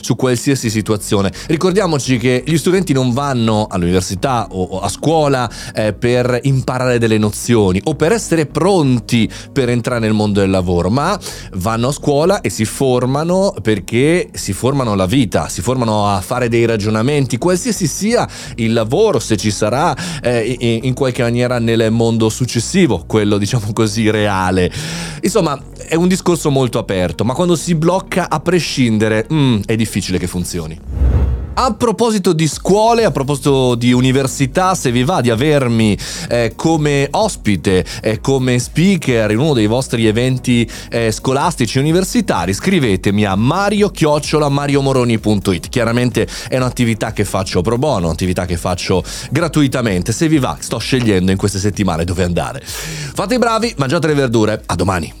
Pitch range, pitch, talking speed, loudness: 105-150 Hz, 125 Hz, 155 wpm, -15 LUFS